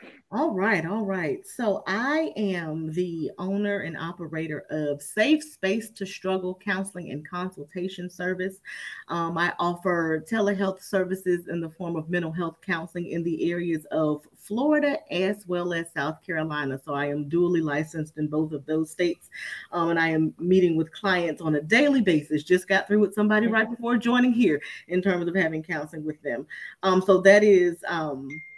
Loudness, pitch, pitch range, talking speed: -25 LUFS, 180 Hz, 160-200 Hz, 175 wpm